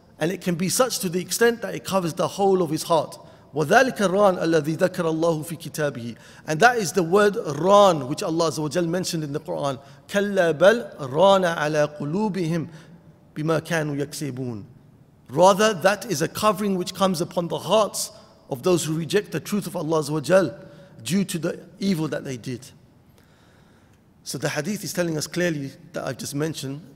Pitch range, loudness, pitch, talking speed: 150-190 Hz, -22 LUFS, 170 Hz, 180 wpm